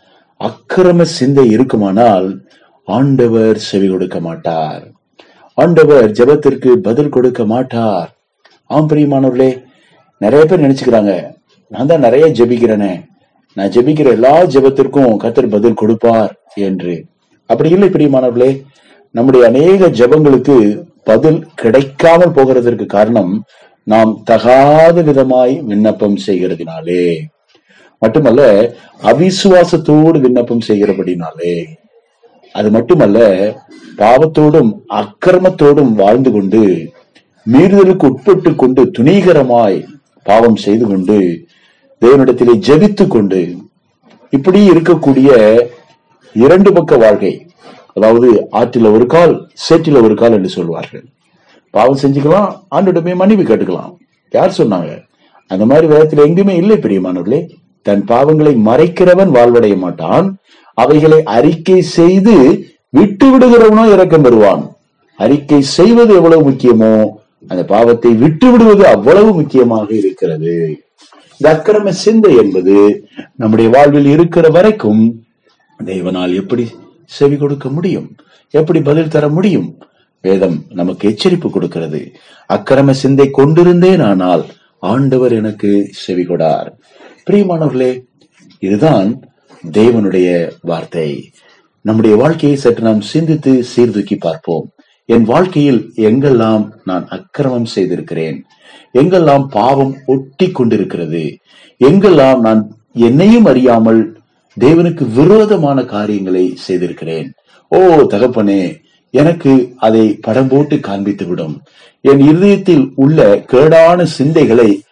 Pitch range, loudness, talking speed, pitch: 110-160 Hz, -9 LUFS, 85 wpm, 130 Hz